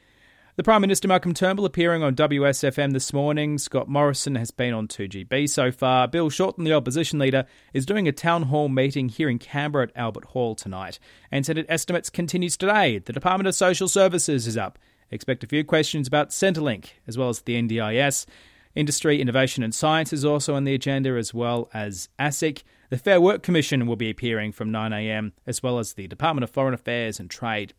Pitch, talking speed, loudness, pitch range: 135 Hz, 195 wpm, -23 LUFS, 120-160 Hz